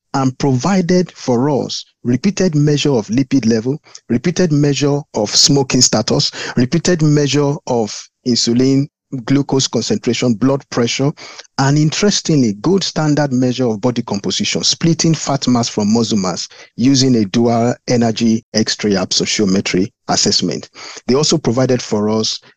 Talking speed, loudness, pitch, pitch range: 130 wpm, -15 LUFS, 135 Hz, 120-150 Hz